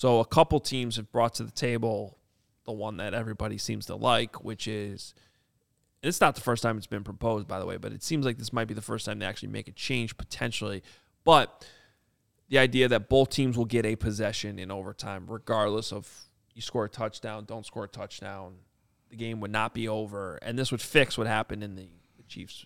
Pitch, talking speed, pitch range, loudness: 110 Hz, 215 wpm, 105-120 Hz, -29 LUFS